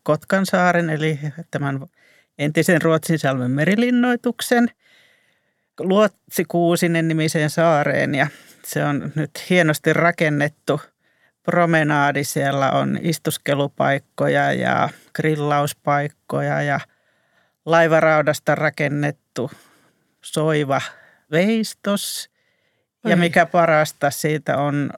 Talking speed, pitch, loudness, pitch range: 80 wpm, 155 Hz, -19 LUFS, 145-175 Hz